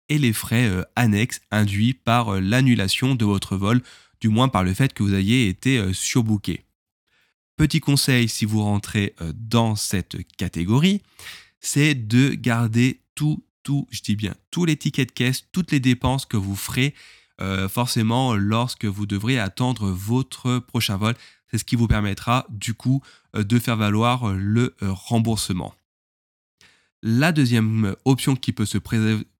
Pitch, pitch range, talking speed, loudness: 115 Hz, 105-130 Hz, 155 wpm, -22 LUFS